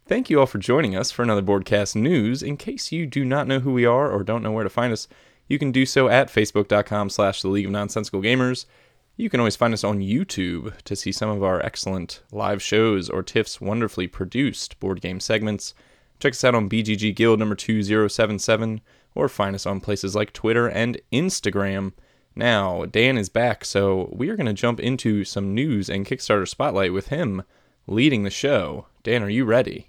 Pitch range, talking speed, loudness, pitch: 100-120 Hz, 200 wpm, -22 LUFS, 105 Hz